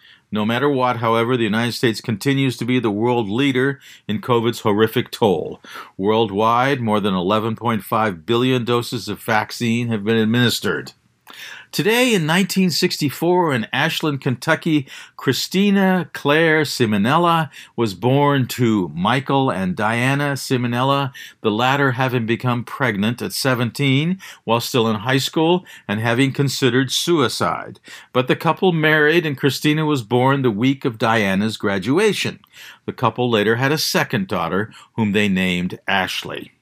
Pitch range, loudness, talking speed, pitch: 115-145 Hz, -19 LUFS, 140 wpm, 125 Hz